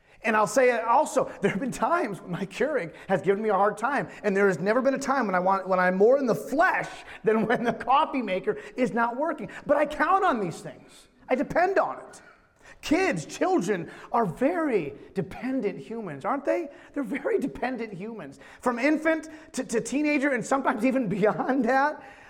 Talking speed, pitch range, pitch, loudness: 200 wpm, 220-290 Hz, 255 Hz, -26 LUFS